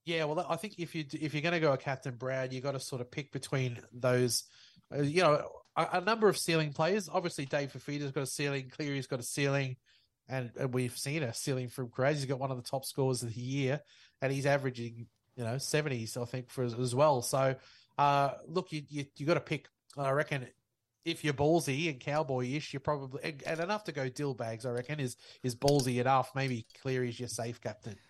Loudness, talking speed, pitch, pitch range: -34 LUFS, 230 wpm, 135 Hz, 125-150 Hz